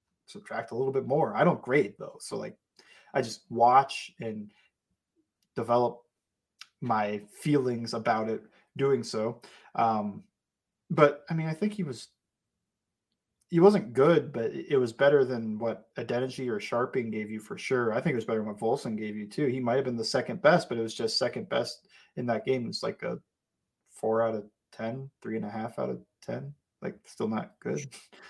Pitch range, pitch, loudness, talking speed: 110-145 Hz, 120 Hz, -29 LUFS, 190 wpm